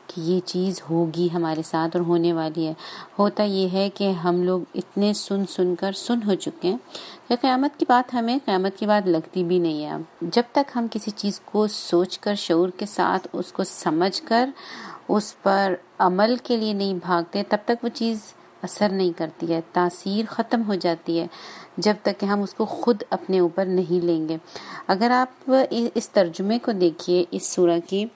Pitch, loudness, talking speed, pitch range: 195 Hz, -23 LUFS, 200 wpm, 175-225 Hz